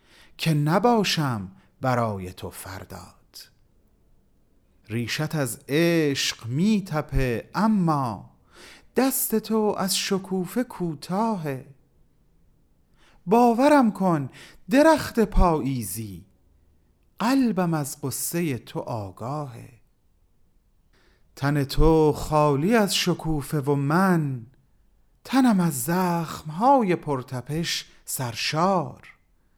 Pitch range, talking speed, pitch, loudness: 125-190 Hz, 75 wpm, 150 Hz, -23 LUFS